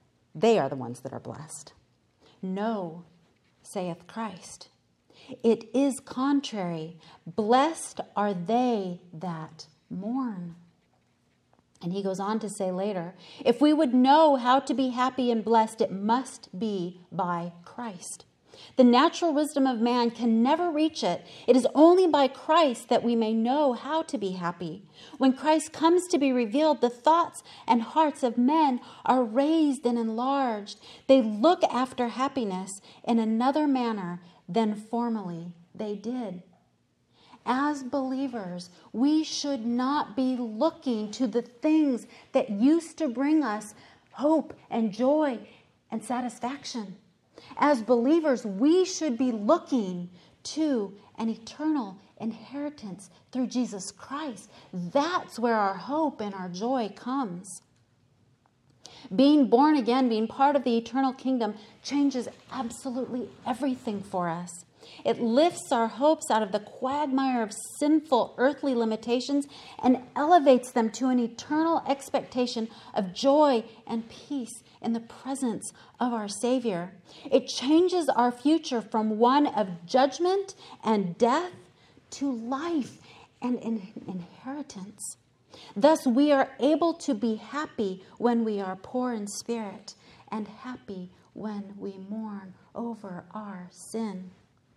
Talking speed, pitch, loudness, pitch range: 130 wpm, 240 Hz, -27 LUFS, 205-275 Hz